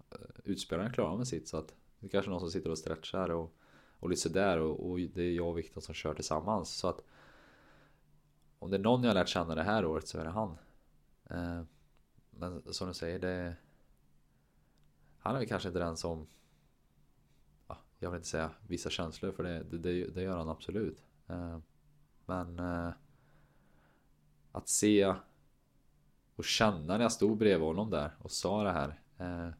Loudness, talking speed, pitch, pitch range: -35 LUFS, 185 wpm, 85 Hz, 75-90 Hz